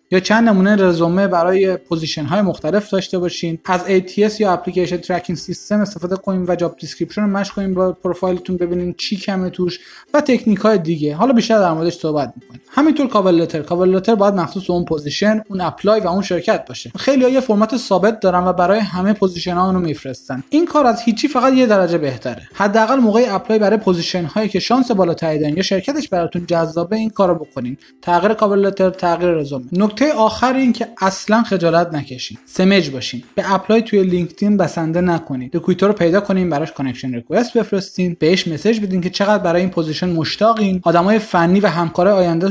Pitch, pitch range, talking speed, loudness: 185 Hz, 170-210 Hz, 185 wpm, -16 LUFS